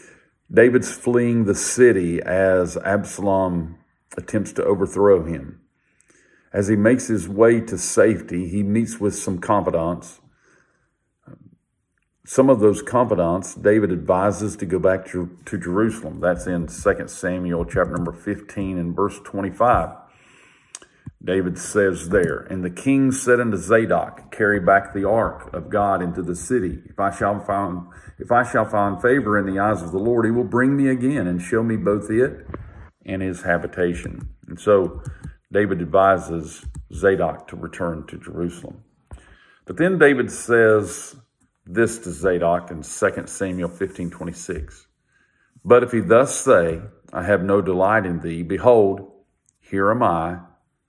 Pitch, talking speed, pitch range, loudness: 95 Hz, 145 wpm, 90-110 Hz, -20 LUFS